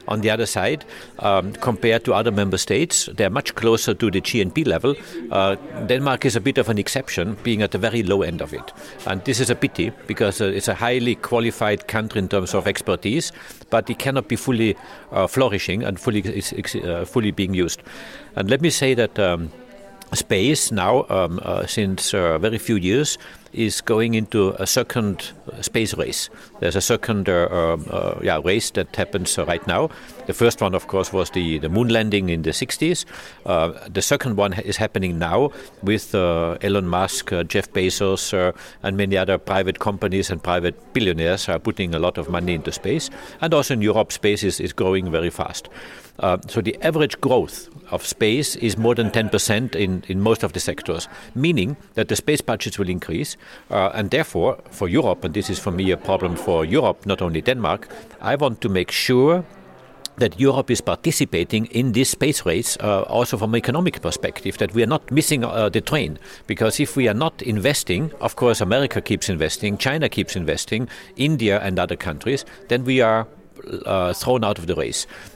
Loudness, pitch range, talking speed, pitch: -21 LUFS, 95-120 Hz, 195 wpm, 105 Hz